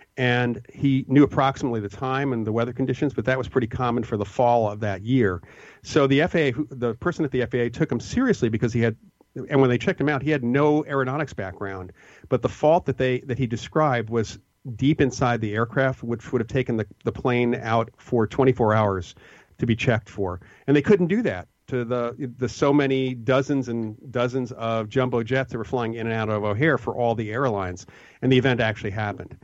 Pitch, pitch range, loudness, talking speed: 125 Hz, 115-135 Hz, -23 LUFS, 220 wpm